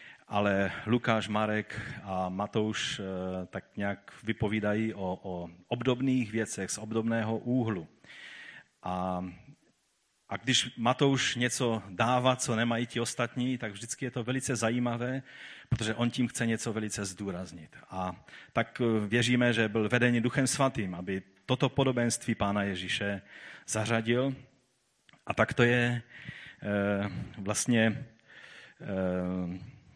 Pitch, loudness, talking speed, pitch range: 110 Hz, -31 LUFS, 120 wpm, 100-125 Hz